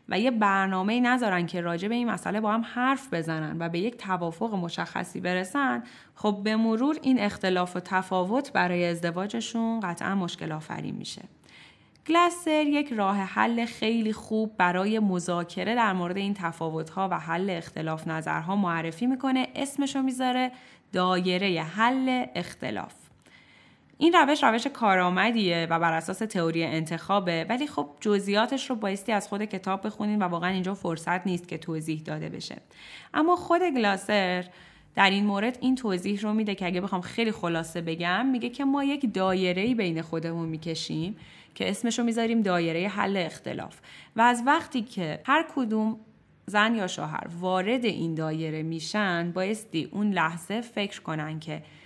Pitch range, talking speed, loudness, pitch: 175-230 Hz, 155 wpm, -27 LUFS, 195 Hz